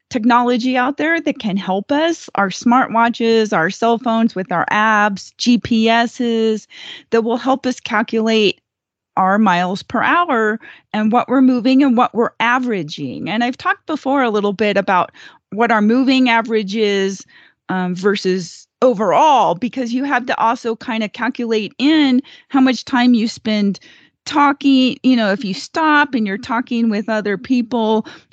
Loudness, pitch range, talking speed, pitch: -16 LUFS, 210-255 Hz, 160 wpm, 230 Hz